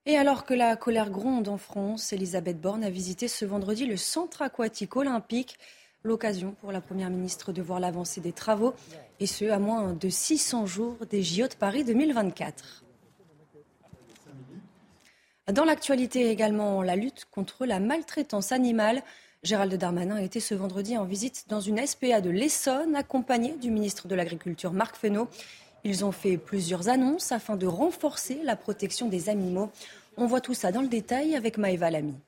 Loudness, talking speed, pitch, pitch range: -29 LUFS, 170 wpm, 215 Hz, 190-245 Hz